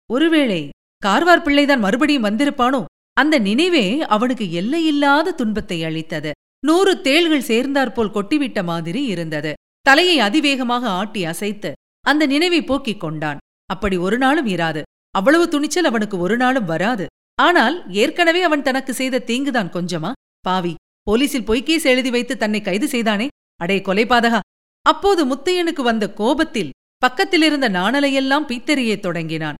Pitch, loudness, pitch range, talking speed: 250 Hz, -18 LUFS, 195-290 Hz, 120 wpm